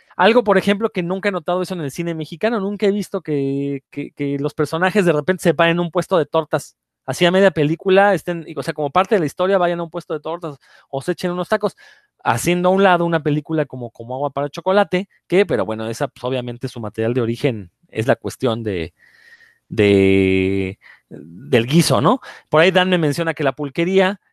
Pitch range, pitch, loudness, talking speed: 140-185 Hz, 170 Hz, -18 LUFS, 220 wpm